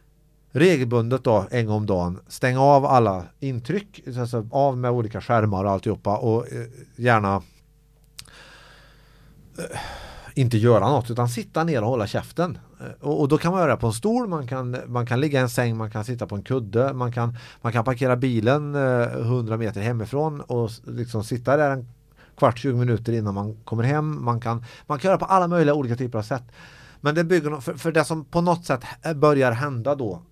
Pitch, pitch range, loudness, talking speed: 125 Hz, 115-150 Hz, -23 LUFS, 190 wpm